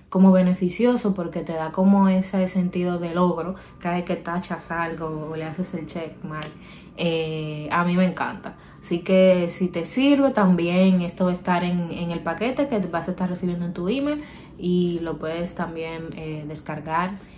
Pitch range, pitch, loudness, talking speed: 165-185 Hz, 175 Hz, -23 LUFS, 185 wpm